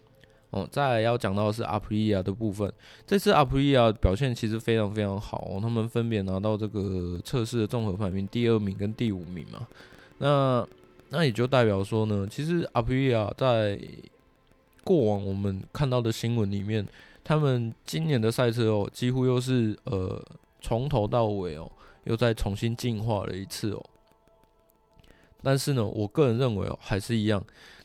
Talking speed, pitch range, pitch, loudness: 260 characters per minute, 100-125 Hz, 110 Hz, -27 LUFS